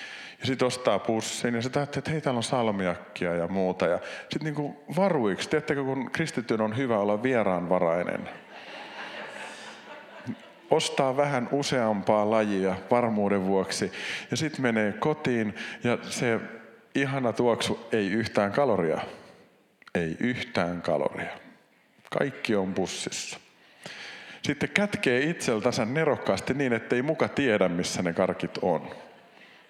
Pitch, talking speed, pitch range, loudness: 120 Hz, 125 wpm, 100-140 Hz, -27 LUFS